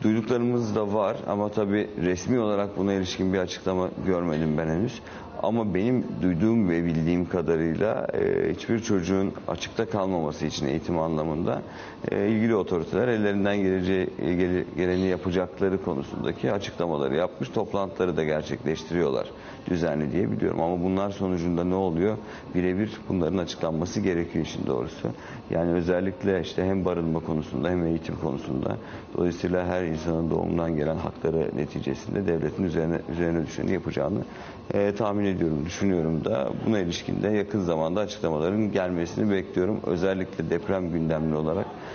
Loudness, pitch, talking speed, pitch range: -27 LUFS, 90 Hz, 130 wpm, 80-100 Hz